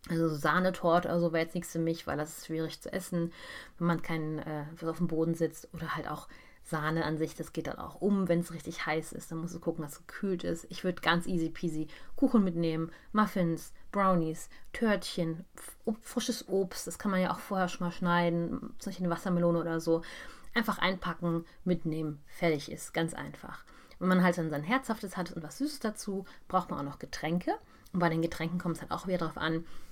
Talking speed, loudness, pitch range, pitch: 220 wpm, -33 LUFS, 165-185 Hz, 170 Hz